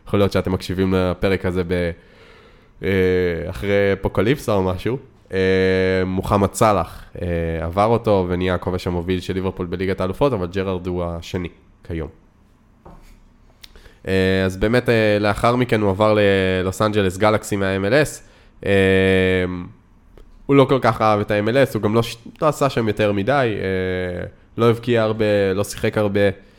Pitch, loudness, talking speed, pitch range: 100 Hz, -19 LUFS, 130 wpm, 95-110 Hz